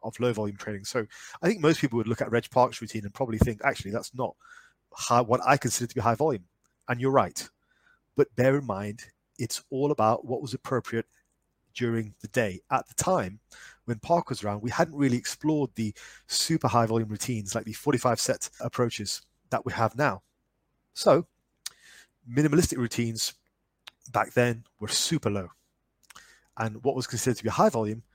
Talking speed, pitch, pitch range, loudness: 185 wpm, 120 Hz, 110-130 Hz, -28 LUFS